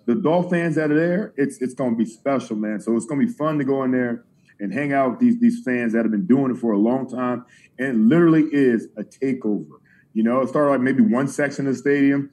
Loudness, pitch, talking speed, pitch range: -20 LUFS, 135 Hz, 265 wpm, 120-150 Hz